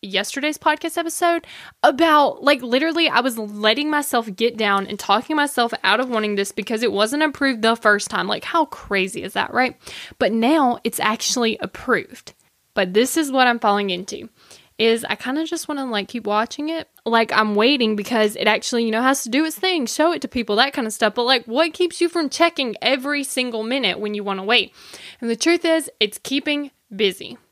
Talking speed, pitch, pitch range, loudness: 215 wpm, 245 Hz, 215-295 Hz, -20 LUFS